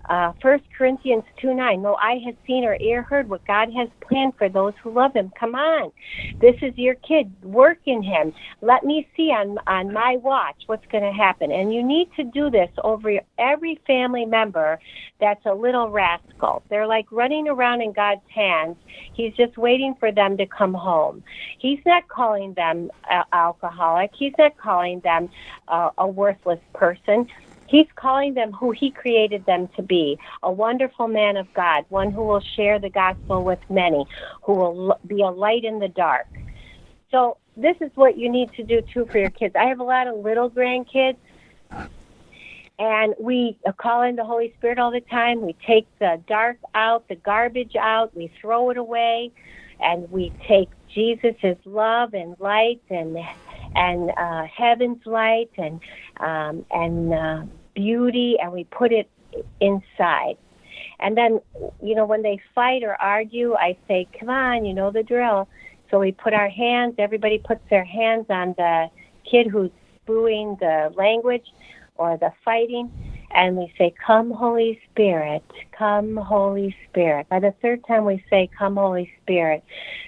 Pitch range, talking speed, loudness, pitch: 190-240 Hz, 170 wpm, -21 LUFS, 220 Hz